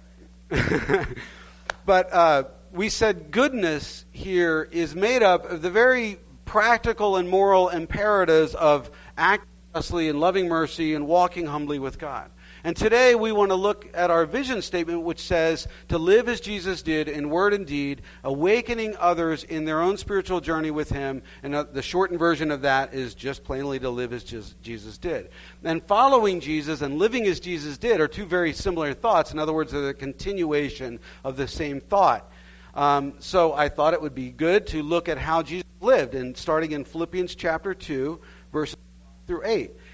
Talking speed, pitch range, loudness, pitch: 180 wpm, 140-185 Hz, -24 LUFS, 160 Hz